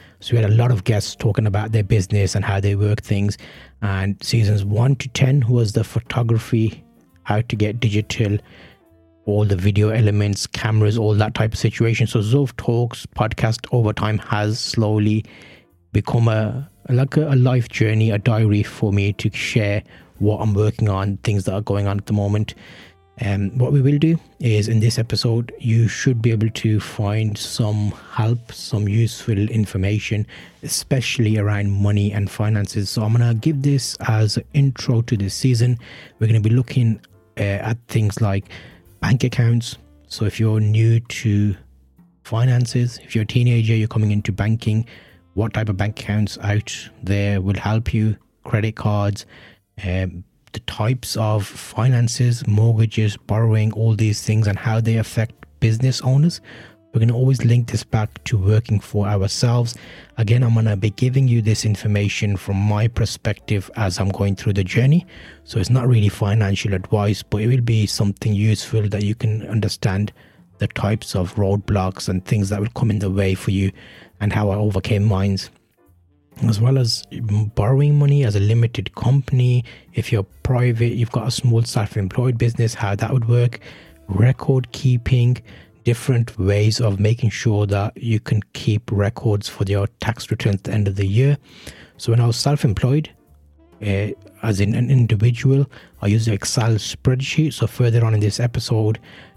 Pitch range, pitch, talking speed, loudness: 105-120 Hz, 110 Hz, 175 wpm, -19 LUFS